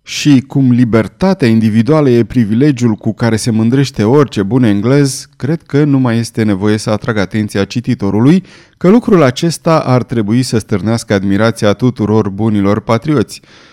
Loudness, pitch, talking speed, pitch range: -12 LUFS, 115 Hz, 150 wpm, 110-140 Hz